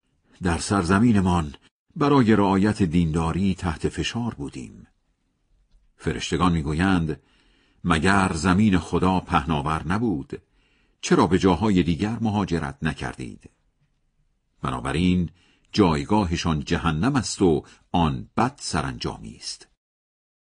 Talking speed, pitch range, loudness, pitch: 90 wpm, 80-100 Hz, -23 LUFS, 90 Hz